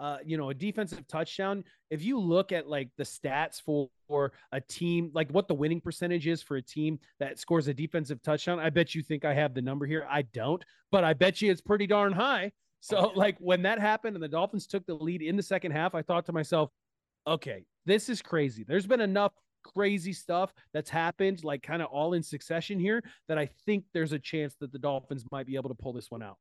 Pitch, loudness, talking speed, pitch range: 165 Hz, -31 LUFS, 235 wpm, 150-195 Hz